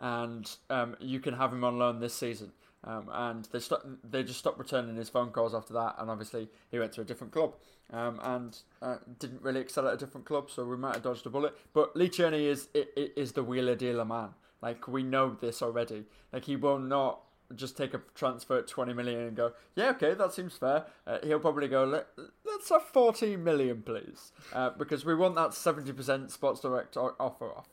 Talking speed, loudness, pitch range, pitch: 210 wpm, -33 LUFS, 120-140 Hz, 130 Hz